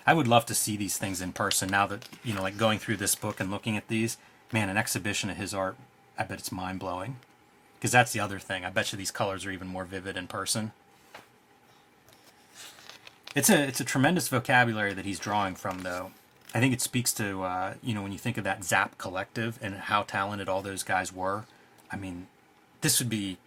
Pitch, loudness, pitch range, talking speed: 100 Hz, -29 LUFS, 95-115 Hz, 220 wpm